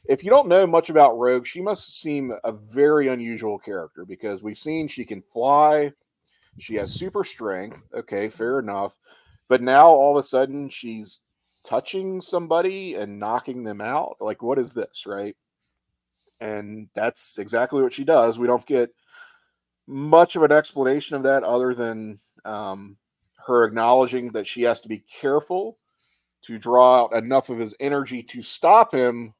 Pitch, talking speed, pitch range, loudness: 130 Hz, 165 wpm, 115-150 Hz, -20 LUFS